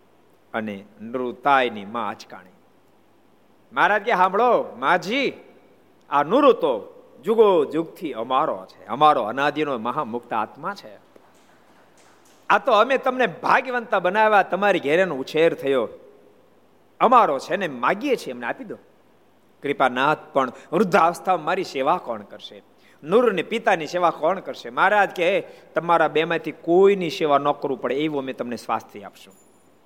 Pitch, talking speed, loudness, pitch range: 170 Hz, 135 wpm, -21 LUFS, 145-230 Hz